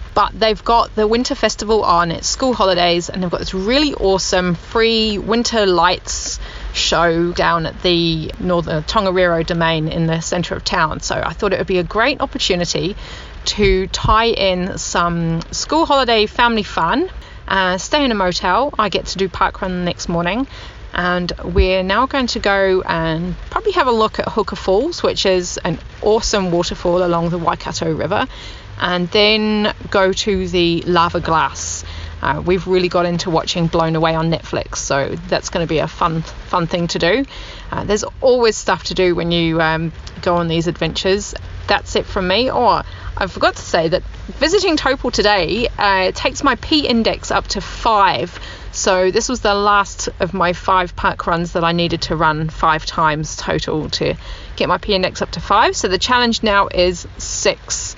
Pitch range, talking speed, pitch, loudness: 170-215 Hz, 185 wpm, 185 Hz, -17 LUFS